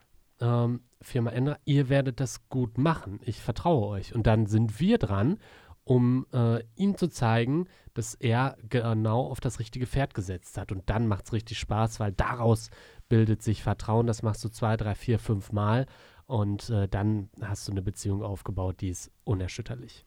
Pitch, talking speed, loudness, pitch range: 115 Hz, 175 wpm, -29 LUFS, 105-125 Hz